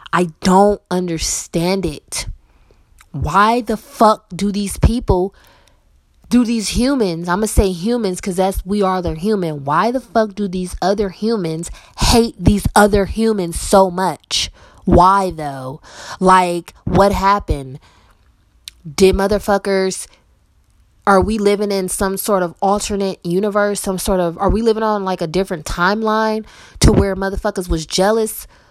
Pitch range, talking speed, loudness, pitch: 180-210 Hz, 145 wpm, -16 LUFS, 195 Hz